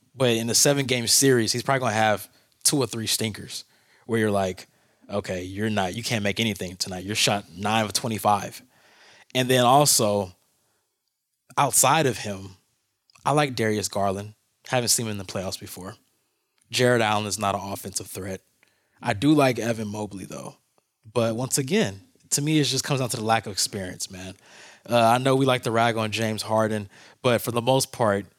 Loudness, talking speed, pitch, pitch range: -23 LUFS, 195 wpm, 110 Hz, 100-125 Hz